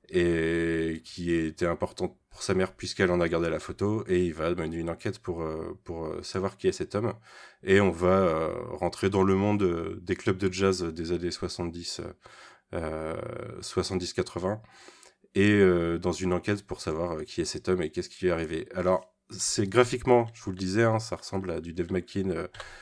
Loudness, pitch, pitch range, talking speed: -29 LUFS, 90 Hz, 85-95 Hz, 195 wpm